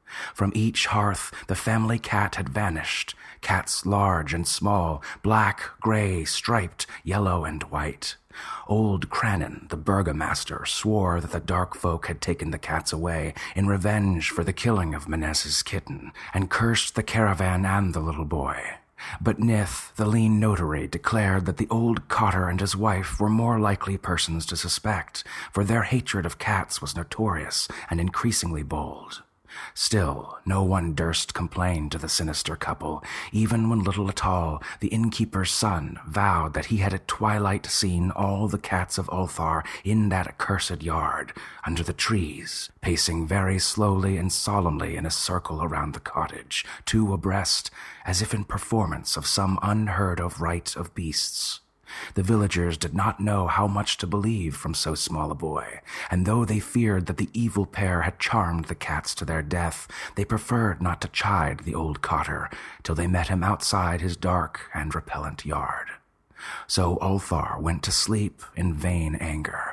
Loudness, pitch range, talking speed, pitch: -25 LUFS, 85-105 Hz, 165 wpm, 95 Hz